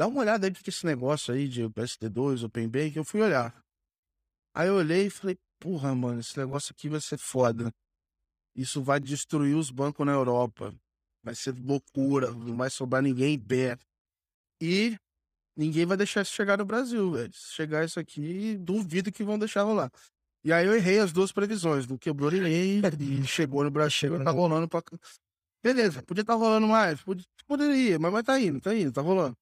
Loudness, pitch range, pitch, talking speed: -28 LUFS, 125-190 Hz, 150 Hz, 190 wpm